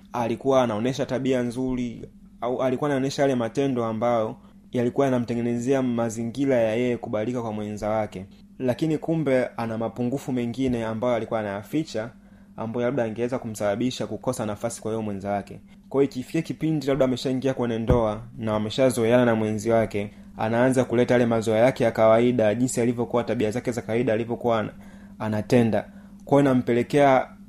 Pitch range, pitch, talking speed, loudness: 110-130 Hz, 120 Hz, 135 wpm, -24 LUFS